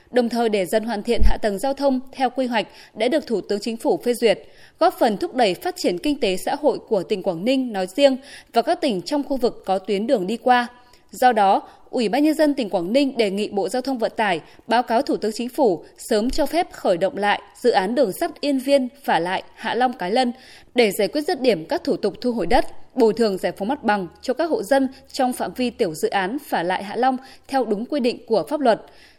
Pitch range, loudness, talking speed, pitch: 215-275 Hz, -21 LUFS, 260 wpm, 245 Hz